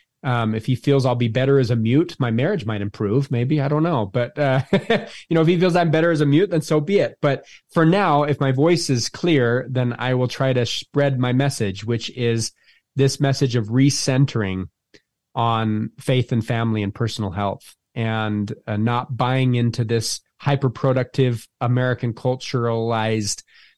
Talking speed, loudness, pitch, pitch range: 180 wpm, -20 LUFS, 125 Hz, 115-140 Hz